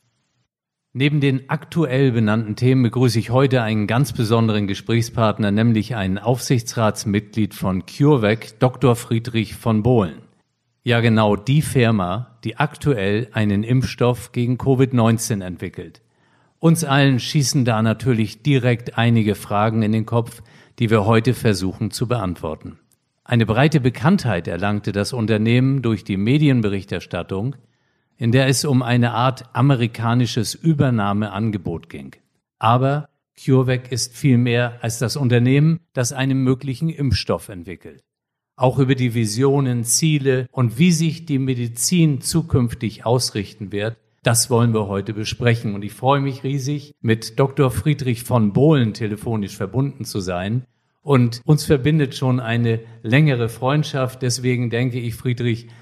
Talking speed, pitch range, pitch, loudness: 130 wpm, 110-135 Hz, 120 Hz, -19 LUFS